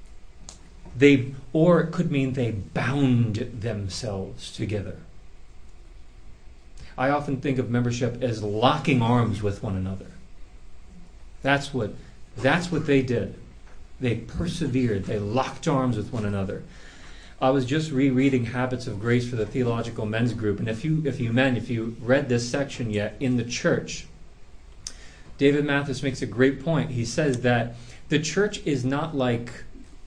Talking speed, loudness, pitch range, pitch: 150 wpm, -25 LUFS, 105-135 Hz, 125 Hz